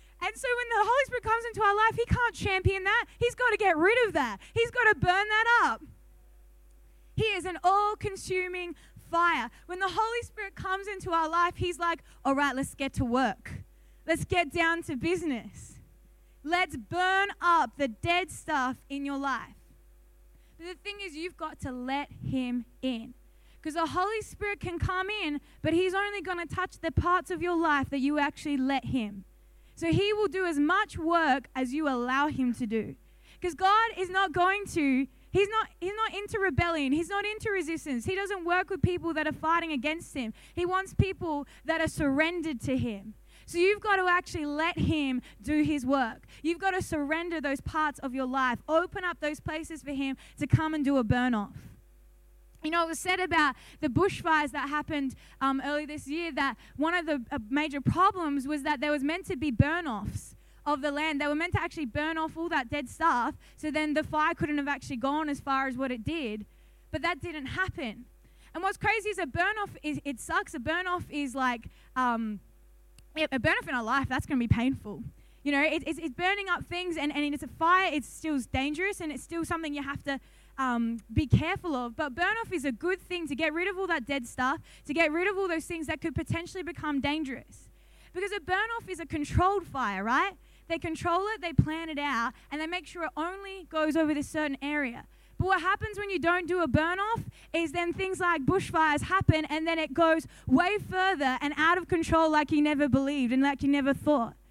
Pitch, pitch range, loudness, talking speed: 320 Hz, 280-365 Hz, -29 LUFS, 215 wpm